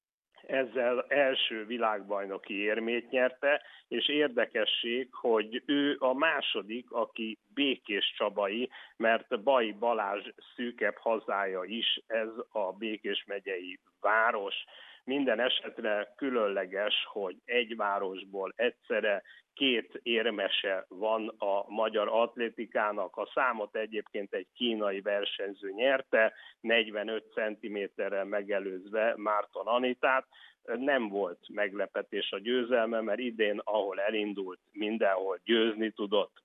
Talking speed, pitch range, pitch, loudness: 100 wpm, 105-120 Hz, 110 Hz, -31 LUFS